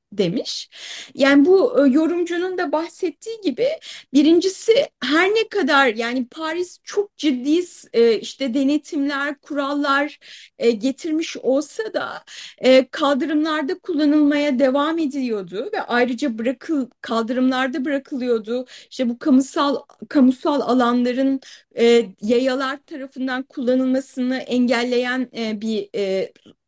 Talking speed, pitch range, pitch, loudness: 105 wpm, 255-315 Hz, 275 Hz, -20 LUFS